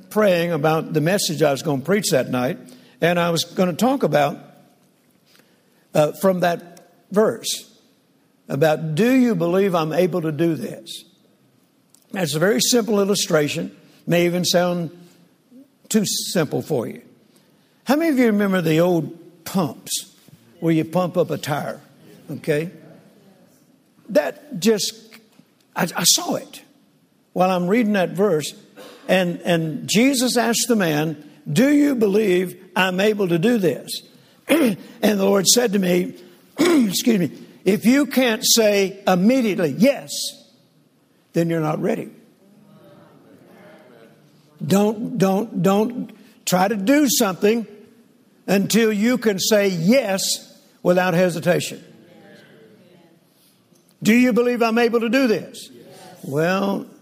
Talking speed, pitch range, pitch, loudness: 135 wpm, 175-235 Hz, 200 Hz, -19 LUFS